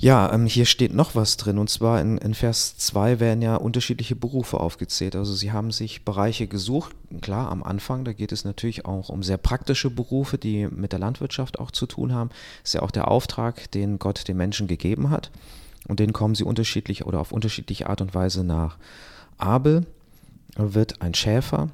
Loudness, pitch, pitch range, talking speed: -24 LUFS, 110 Hz, 100-120 Hz, 200 wpm